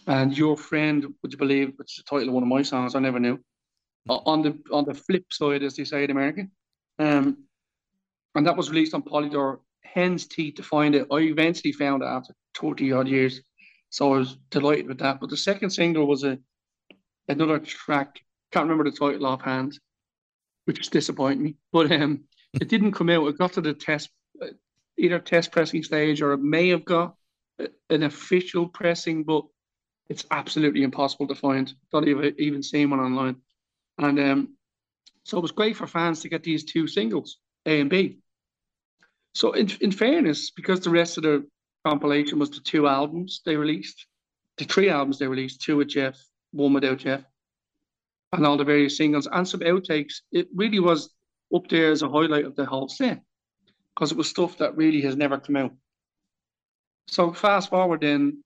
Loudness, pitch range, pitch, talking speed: -24 LUFS, 140-170 Hz, 150 Hz, 190 wpm